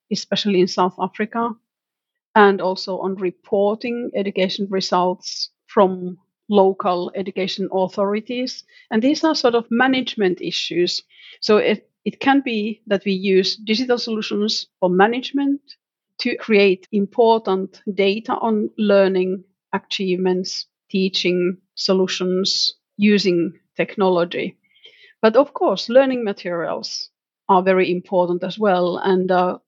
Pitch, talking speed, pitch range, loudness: 195 Hz, 115 wpm, 185-225 Hz, -19 LUFS